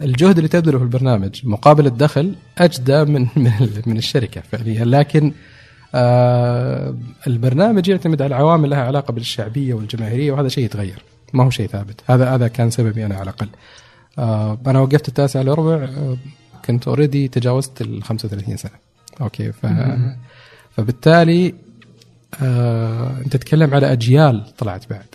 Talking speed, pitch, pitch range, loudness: 130 wpm, 125 Hz, 115-140 Hz, -16 LUFS